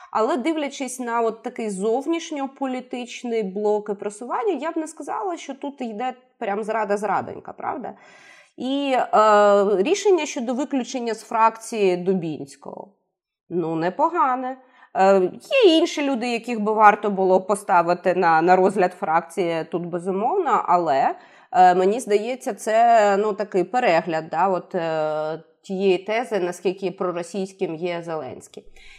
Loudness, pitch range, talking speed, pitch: -21 LUFS, 185-255 Hz, 125 wpm, 215 Hz